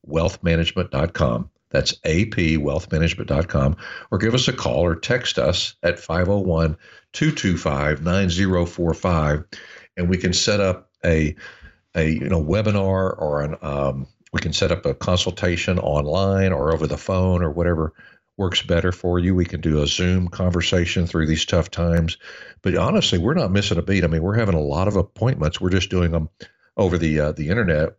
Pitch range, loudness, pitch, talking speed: 80-95 Hz, -21 LUFS, 85 Hz, 165 wpm